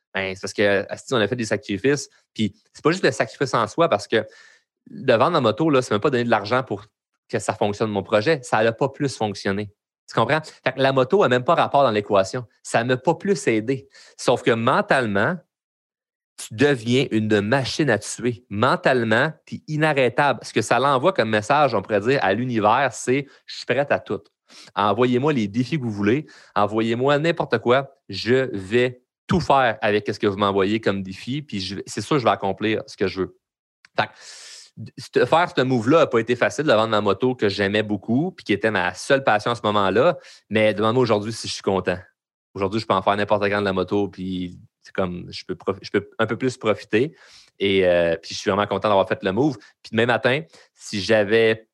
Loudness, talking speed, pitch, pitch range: -21 LUFS, 215 wpm, 110 Hz, 100-130 Hz